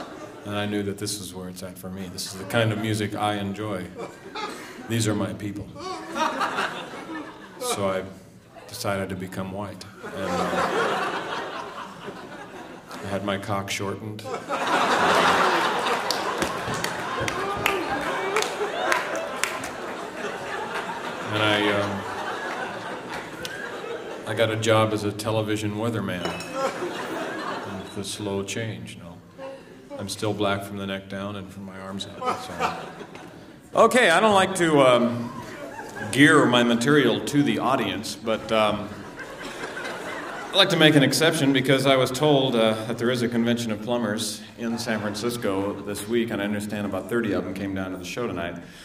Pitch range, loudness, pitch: 100-115 Hz, -24 LUFS, 105 Hz